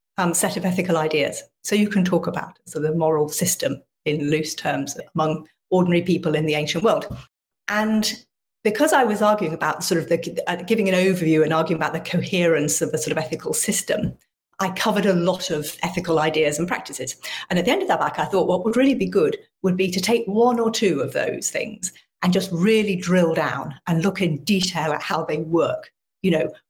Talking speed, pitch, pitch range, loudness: 215 wpm, 180 Hz, 160-205 Hz, -21 LUFS